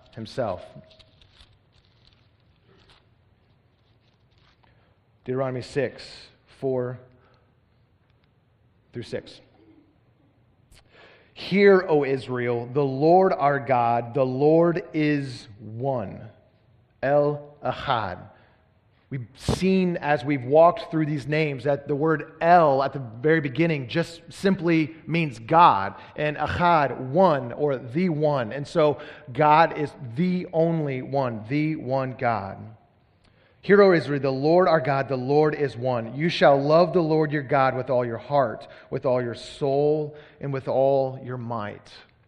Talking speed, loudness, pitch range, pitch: 120 wpm, -23 LUFS, 120-150 Hz, 135 Hz